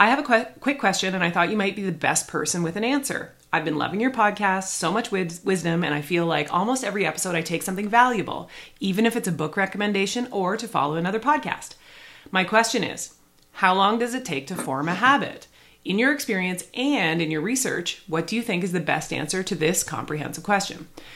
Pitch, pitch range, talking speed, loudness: 190 Hz, 165-225 Hz, 220 wpm, -23 LUFS